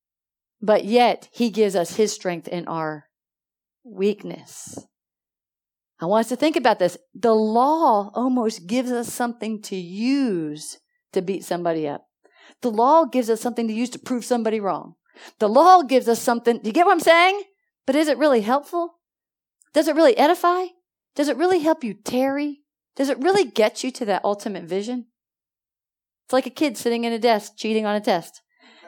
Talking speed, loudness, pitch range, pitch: 180 wpm, -21 LUFS, 210-290 Hz, 240 Hz